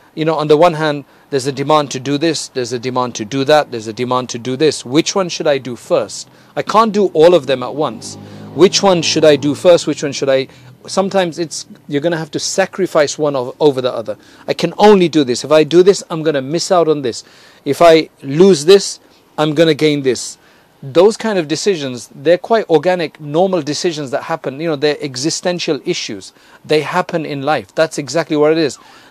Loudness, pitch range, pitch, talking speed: -14 LUFS, 140-175 Hz, 155 Hz, 225 wpm